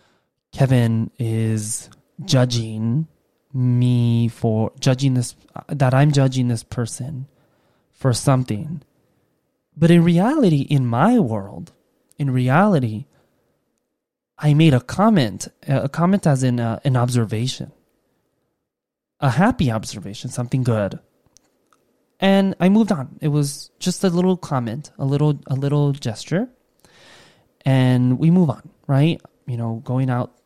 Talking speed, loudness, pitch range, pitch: 120 wpm, -19 LUFS, 120-155 Hz, 135 Hz